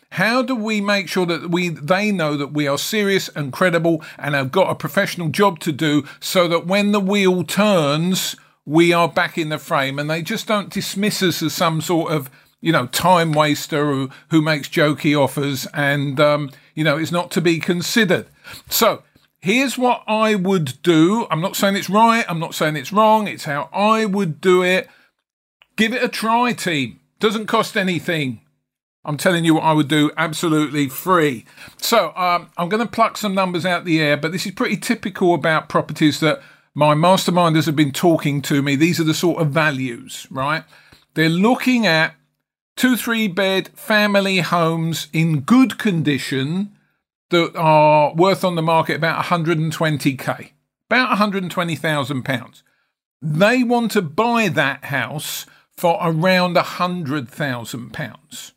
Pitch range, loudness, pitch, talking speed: 150-195 Hz, -18 LUFS, 170 Hz, 170 wpm